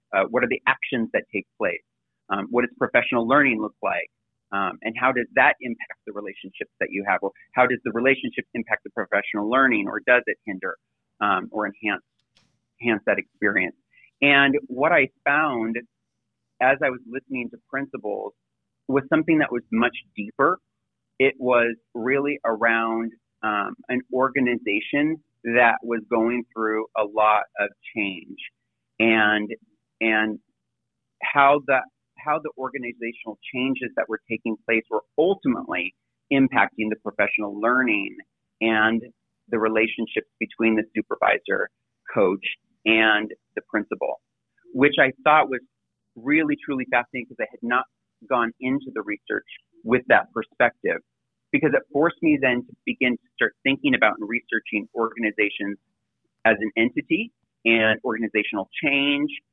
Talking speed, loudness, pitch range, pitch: 145 wpm, -23 LUFS, 110-135 Hz, 120 Hz